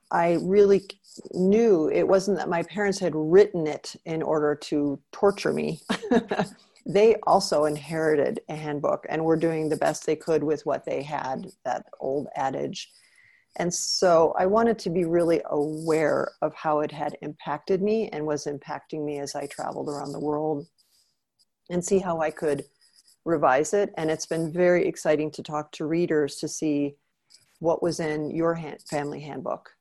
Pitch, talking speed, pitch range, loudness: 160 Hz, 170 wpm, 150-185 Hz, -25 LUFS